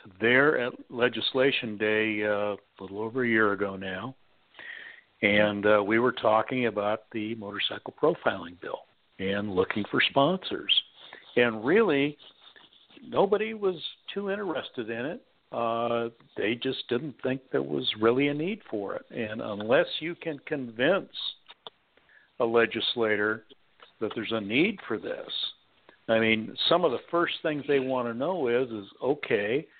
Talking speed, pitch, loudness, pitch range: 145 wpm, 115 Hz, -27 LUFS, 105-135 Hz